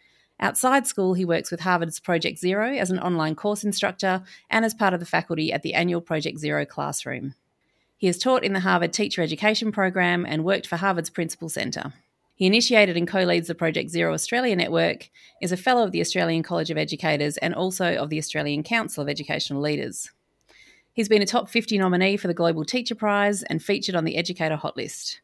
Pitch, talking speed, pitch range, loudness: 180 Hz, 200 wpm, 160-205 Hz, -24 LUFS